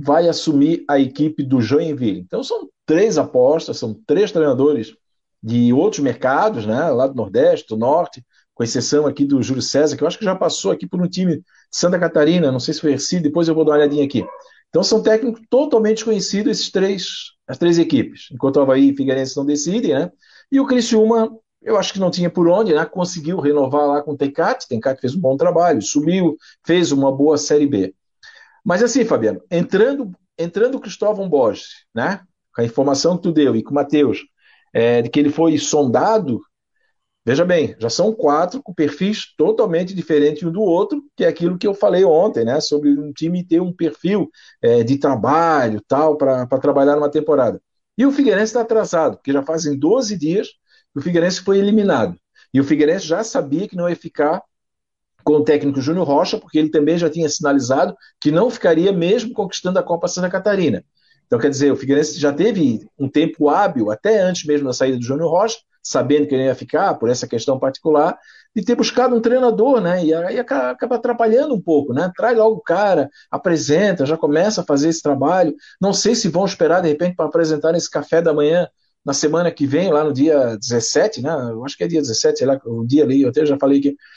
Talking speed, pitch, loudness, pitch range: 210 wpm, 160 Hz, -17 LUFS, 145-200 Hz